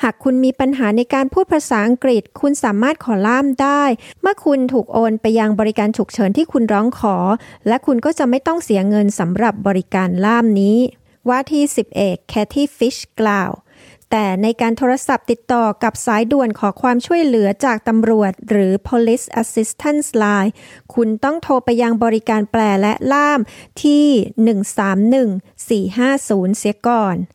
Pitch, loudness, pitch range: 230 Hz, -16 LUFS, 210-265 Hz